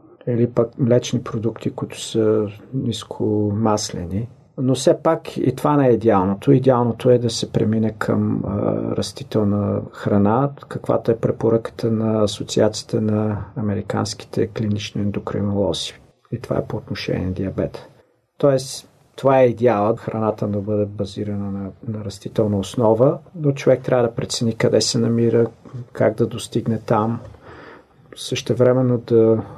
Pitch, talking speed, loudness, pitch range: 115 Hz, 135 wpm, -20 LUFS, 105-125 Hz